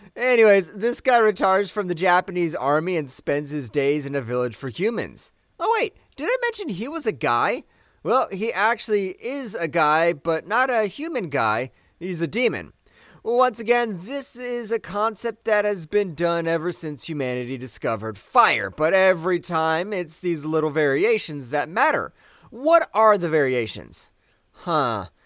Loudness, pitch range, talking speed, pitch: -22 LUFS, 155-230 Hz, 165 wpm, 185 Hz